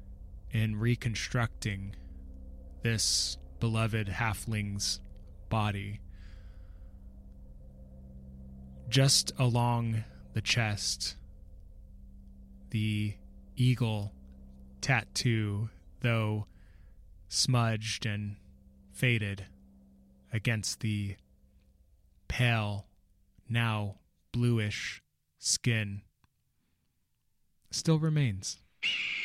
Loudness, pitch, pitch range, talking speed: -31 LUFS, 100 Hz, 70-110 Hz, 50 wpm